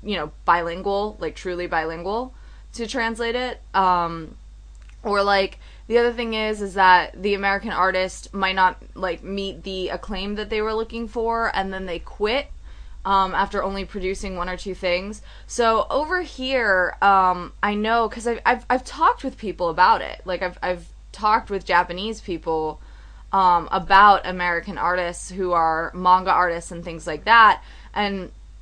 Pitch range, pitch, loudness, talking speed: 180-220 Hz, 195 Hz, -21 LUFS, 165 wpm